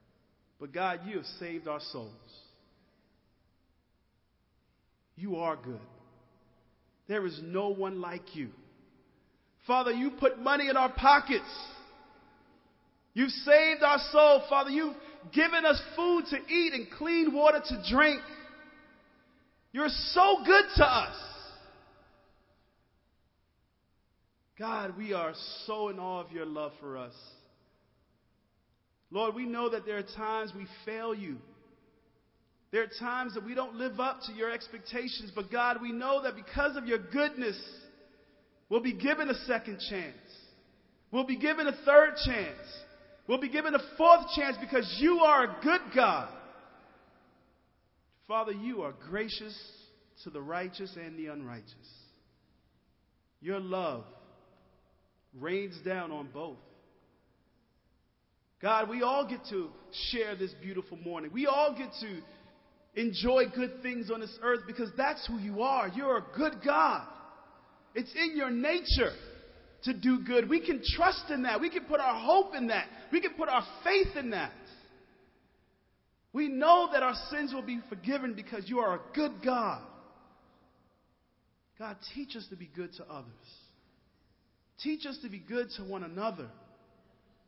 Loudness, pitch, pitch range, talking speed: -30 LUFS, 240 Hz, 195-285 Hz, 145 wpm